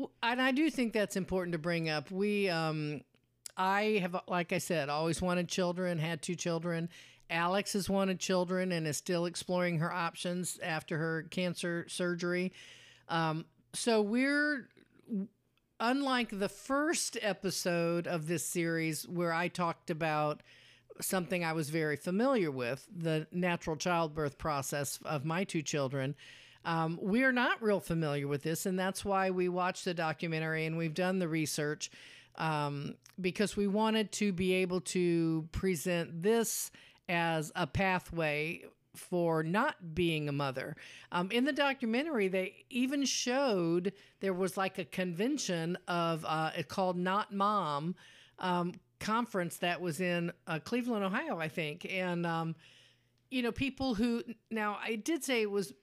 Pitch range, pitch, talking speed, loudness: 165-200 Hz, 180 Hz, 150 wpm, -34 LUFS